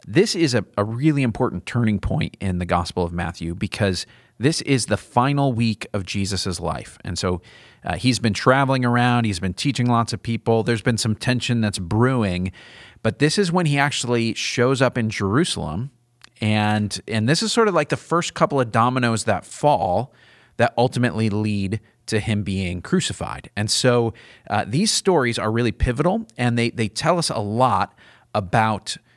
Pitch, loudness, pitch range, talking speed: 115 Hz, -21 LUFS, 105-130 Hz, 180 wpm